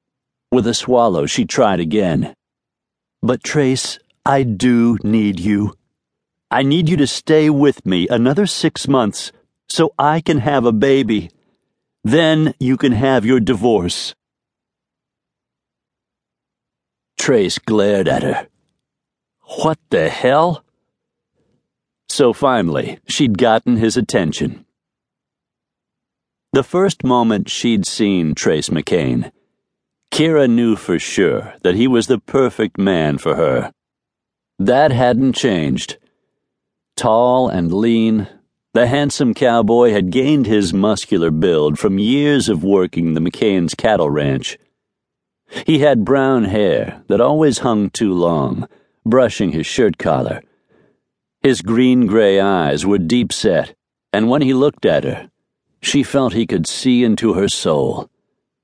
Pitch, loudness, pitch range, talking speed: 120 Hz, -15 LUFS, 105-135 Hz, 125 wpm